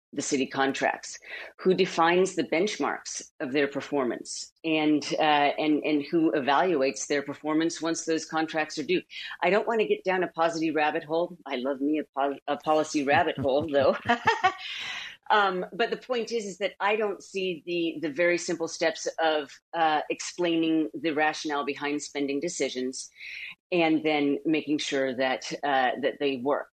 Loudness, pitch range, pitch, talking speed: -27 LUFS, 145-175 Hz, 160 Hz, 170 wpm